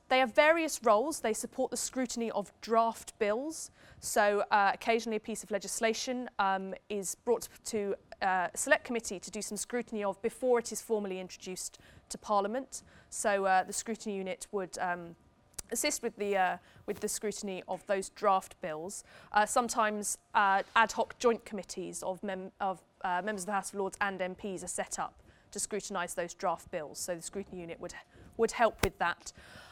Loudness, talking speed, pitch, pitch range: -33 LUFS, 185 wpm, 205 Hz, 190-230 Hz